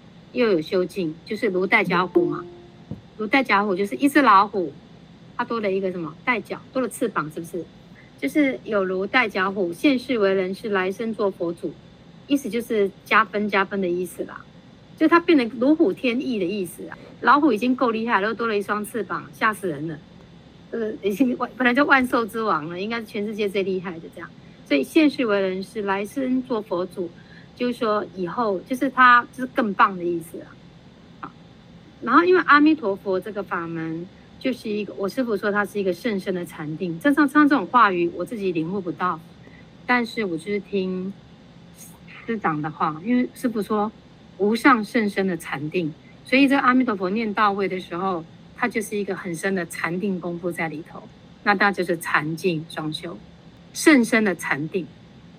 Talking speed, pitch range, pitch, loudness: 275 characters per minute, 180-235 Hz, 200 Hz, -22 LUFS